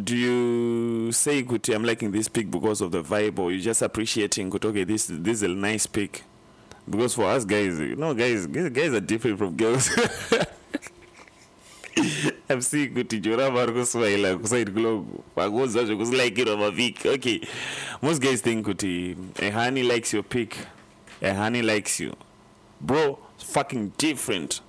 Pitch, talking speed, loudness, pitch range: 115 Hz, 145 wpm, -25 LUFS, 105-120 Hz